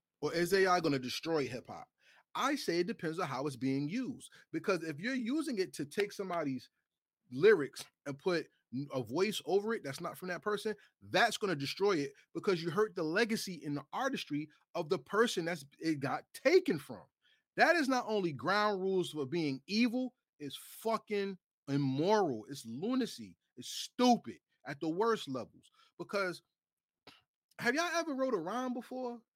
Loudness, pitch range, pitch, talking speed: -35 LUFS, 155-235 Hz, 190 Hz, 175 wpm